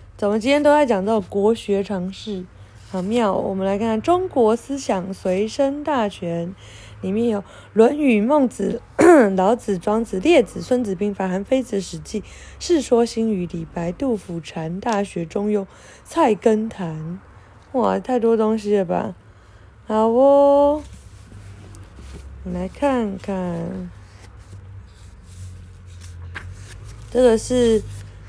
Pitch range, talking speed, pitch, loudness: 155-230 Hz, 175 characters per minute, 200 Hz, -20 LUFS